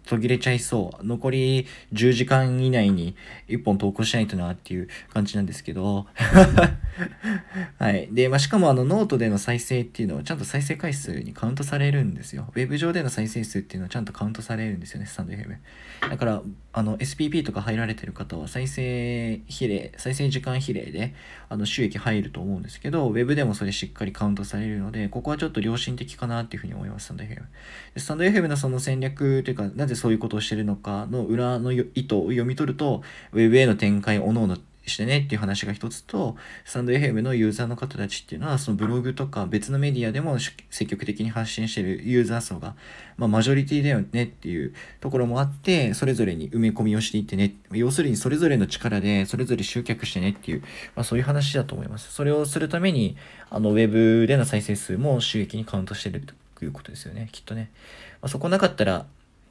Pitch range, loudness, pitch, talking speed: 105-130 Hz, -24 LUFS, 115 Hz, 455 characters per minute